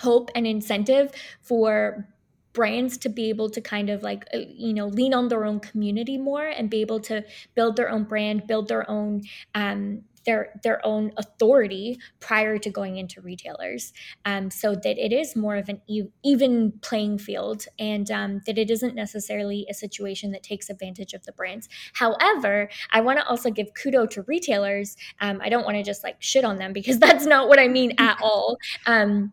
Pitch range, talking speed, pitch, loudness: 205-240 Hz, 190 wpm, 215 Hz, -23 LUFS